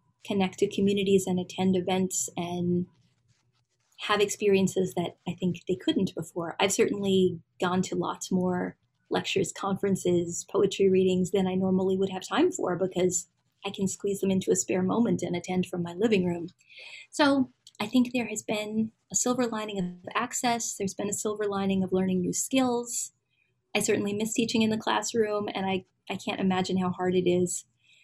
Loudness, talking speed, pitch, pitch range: -28 LUFS, 180 wpm, 190 Hz, 180-205 Hz